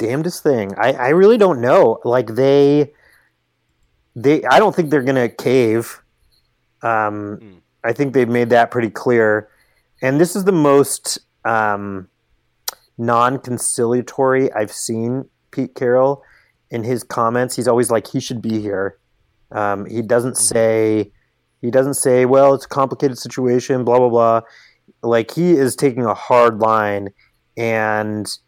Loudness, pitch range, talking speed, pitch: -16 LUFS, 110-130 Hz, 145 wpm, 120 Hz